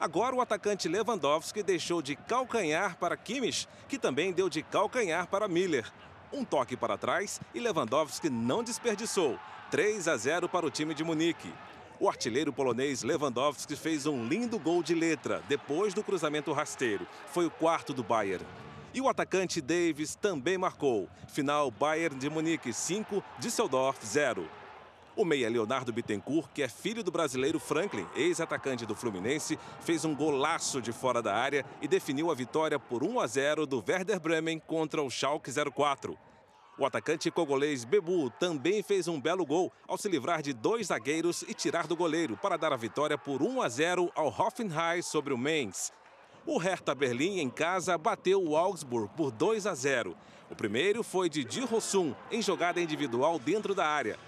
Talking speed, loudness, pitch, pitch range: 170 wpm, -31 LUFS, 165 Hz, 150-205 Hz